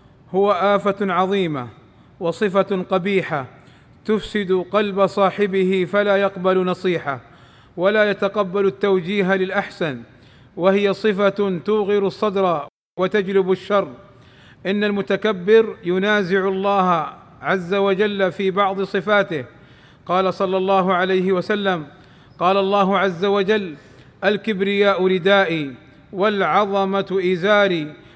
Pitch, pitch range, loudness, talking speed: 195 Hz, 180-200 Hz, -19 LUFS, 90 wpm